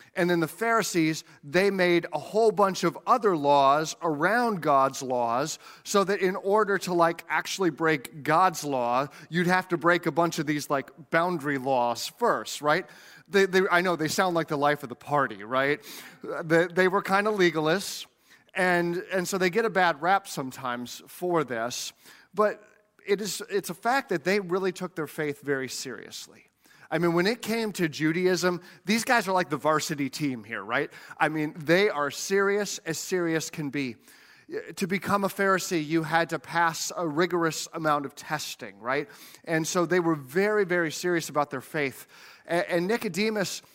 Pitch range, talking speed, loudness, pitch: 150-190 Hz, 180 wpm, -26 LUFS, 170 Hz